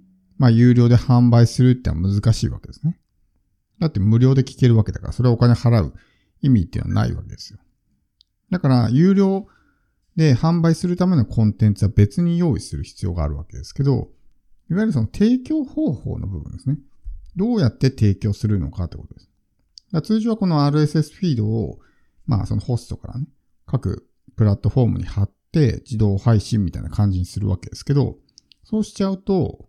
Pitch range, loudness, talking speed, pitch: 100-145 Hz, -19 LUFS, 385 characters per minute, 115 Hz